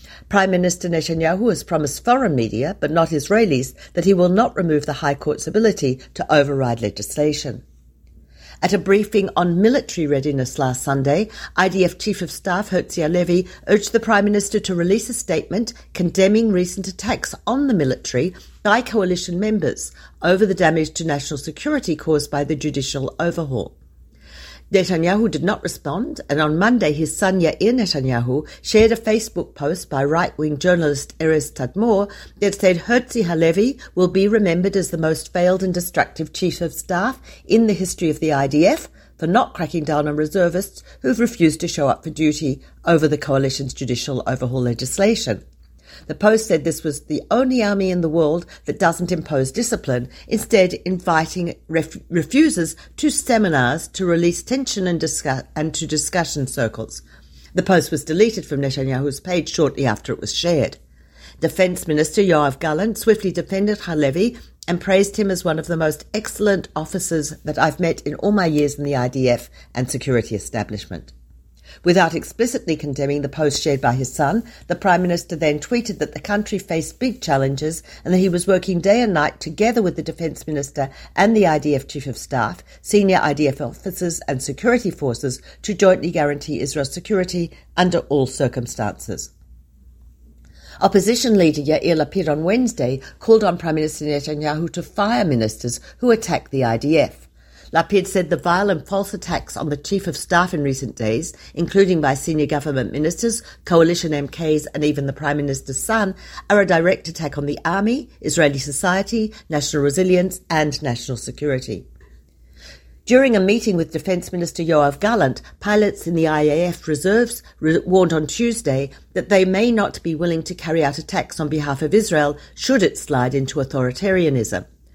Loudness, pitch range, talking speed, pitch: -19 LUFS, 140-190 Hz, 165 wpm, 160 Hz